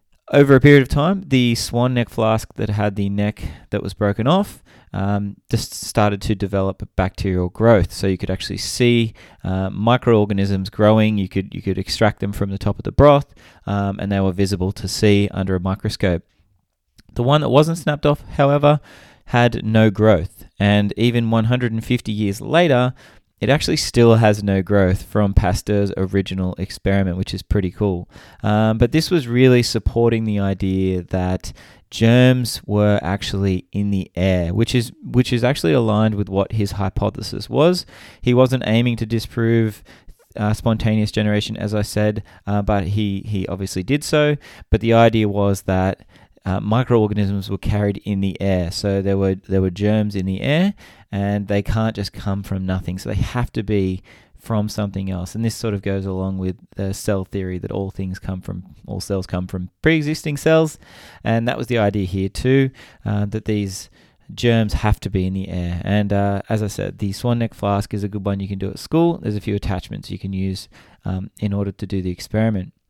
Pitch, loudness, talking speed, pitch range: 105 Hz, -19 LUFS, 190 wpm, 95-115 Hz